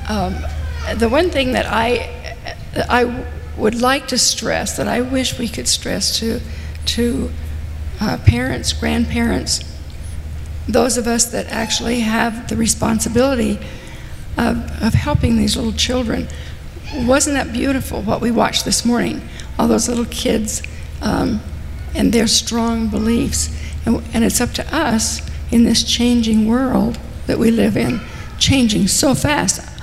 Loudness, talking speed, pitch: -17 LUFS, 145 wpm, 225 Hz